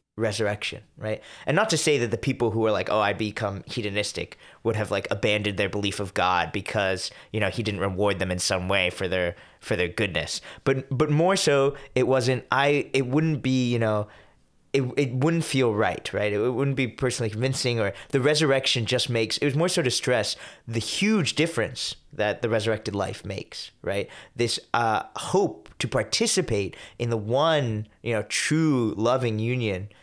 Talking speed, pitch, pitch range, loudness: 190 wpm, 120 Hz, 105-135 Hz, -25 LUFS